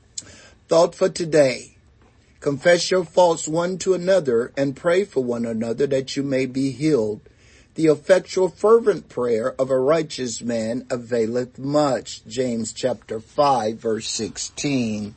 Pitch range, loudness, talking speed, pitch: 115-170 Hz, -21 LUFS, 135 wpm, 130 Hz